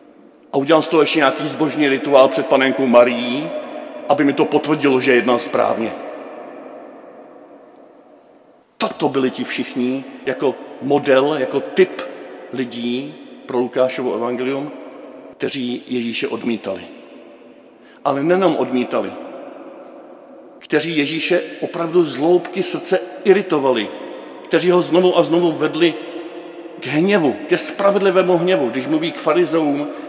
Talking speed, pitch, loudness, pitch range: 115 wpm, 155 Hz, -17 LUFS, 130-185 Hz